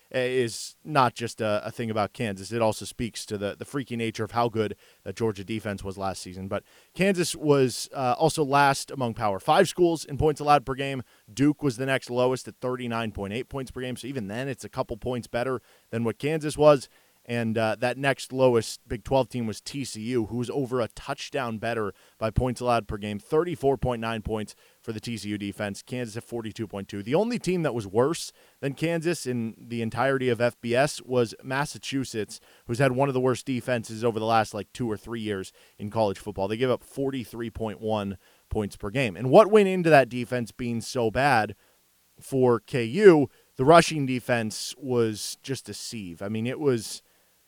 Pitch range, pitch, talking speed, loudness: 110-135 Hz, 120 Hz, 195 wpm, -26 LUFS